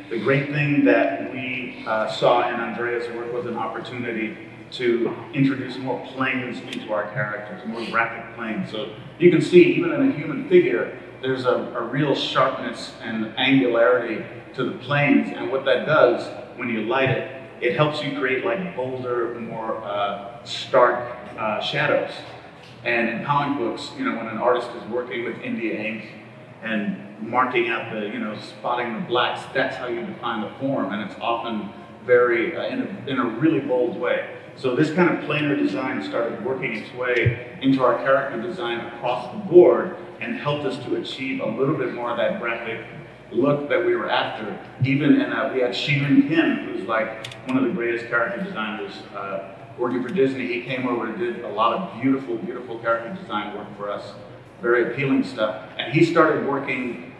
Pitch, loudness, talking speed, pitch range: 125 Hz, -23 LUFS, 185 wpm, 115-150 Hz